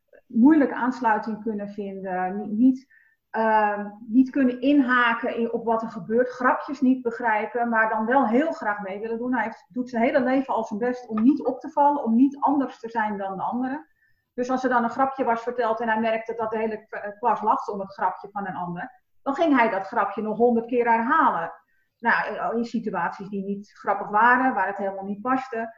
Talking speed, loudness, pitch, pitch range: 210 wpm, -24 LUFS, 230 Hz, 215-255 Hz